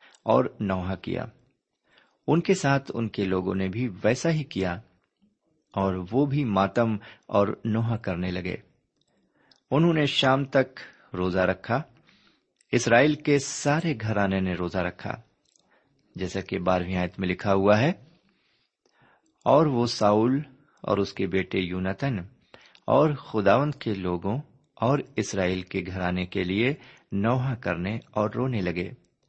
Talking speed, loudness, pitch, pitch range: 135 wpm, -26 LUFS, 110 Hz, 95-135 Hz